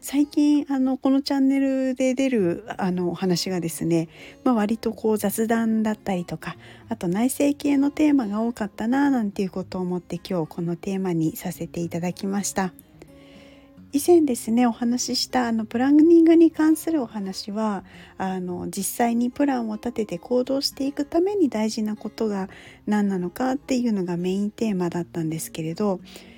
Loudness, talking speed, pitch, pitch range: -23 LUFS, 360 characters per minute, 220 Hz, 180-265 Hz